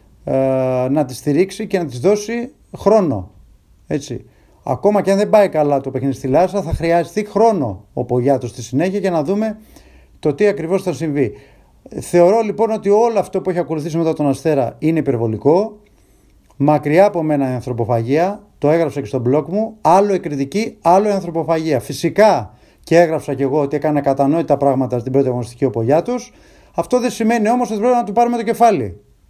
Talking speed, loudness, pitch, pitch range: 180 wpm, -17 LUFS, 160 Hz, 135-205 Hz